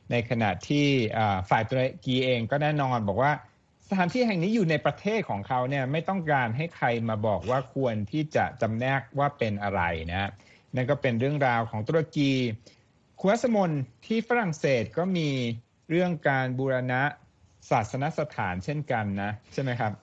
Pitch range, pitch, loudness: 115-150 Hz, 130 Hz, -27 LUFS